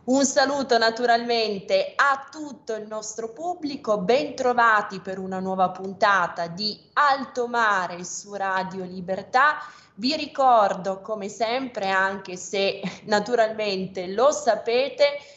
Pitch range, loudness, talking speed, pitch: 195-270 Hz, -23 LUFS, 110 wpm, 225 Hz